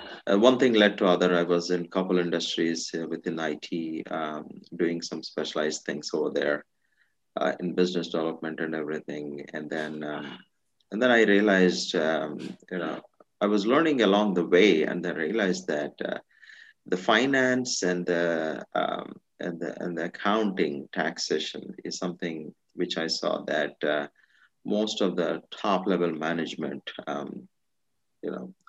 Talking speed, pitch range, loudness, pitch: 155 wpm, 80-95 Hz, -27 LUFS, 85 Hz